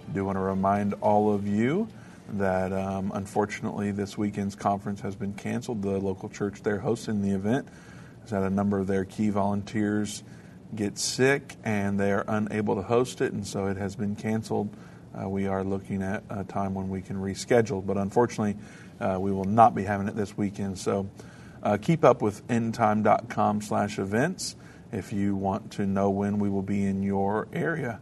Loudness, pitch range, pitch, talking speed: -28 LUFS, 100-105 Hz, 100 Hz, 190 wpm